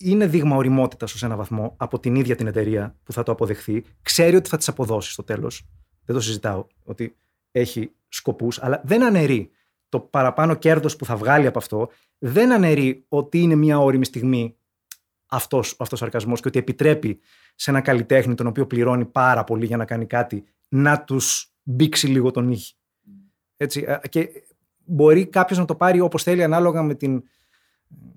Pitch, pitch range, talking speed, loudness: 130 Hz, 115-150 Hz, 175 wpm, -20 LUFS